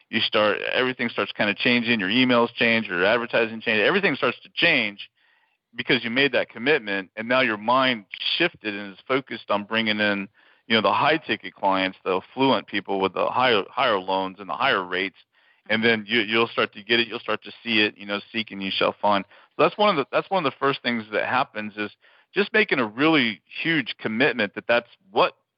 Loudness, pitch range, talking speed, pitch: -22 LUFS, 105-125 Hz, 220 wpm, 115 Hz